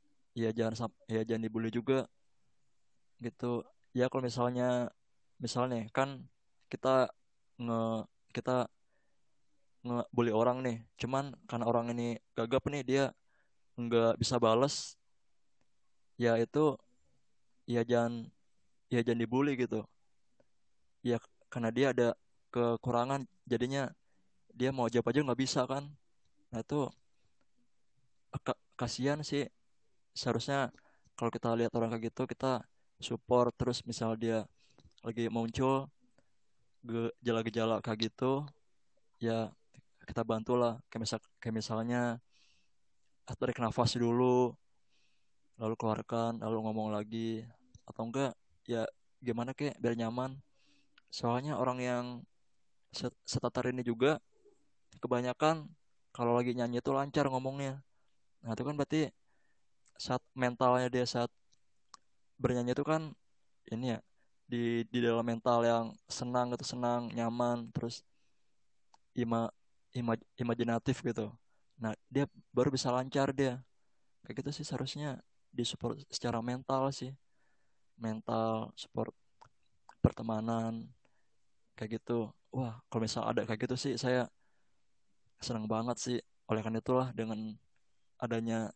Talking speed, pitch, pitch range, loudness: 115 wpm, 120 Hz, 115-130 Hz, -35 LUFS